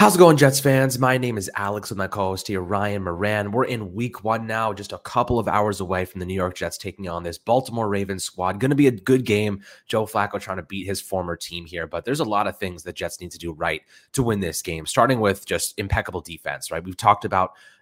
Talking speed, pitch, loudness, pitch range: 265 wpm, 100 Hz, -23 LUFS, 90-115 Hz